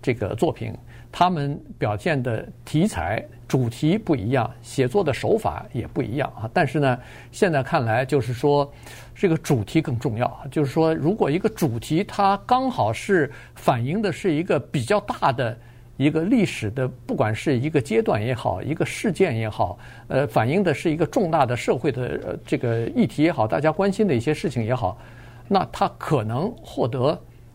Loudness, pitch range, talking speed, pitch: -23 LUFS, 120-165 Hz, 265 characters per minute, 140 Hz